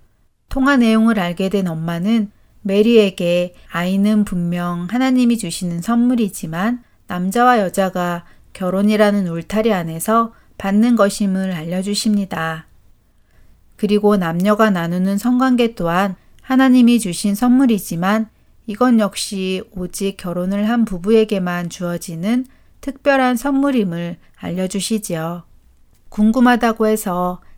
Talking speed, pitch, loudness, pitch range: 270 characters per minute, 200 Hz, -17 LUFS, 175-225 Hz